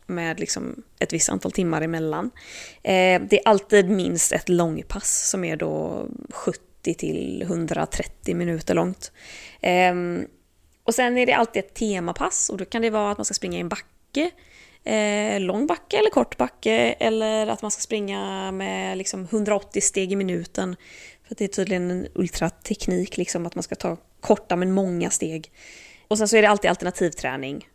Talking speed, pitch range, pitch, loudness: 165 wpm, 175-215 Hz, 190 Hz, -23 LUFS